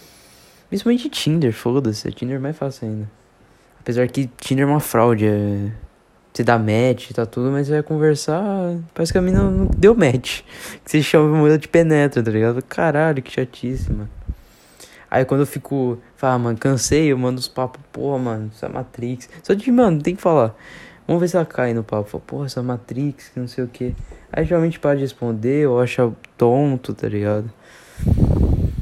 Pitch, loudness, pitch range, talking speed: 130 Hz, -19 LUFS, 115-150 Hz, 190 wpm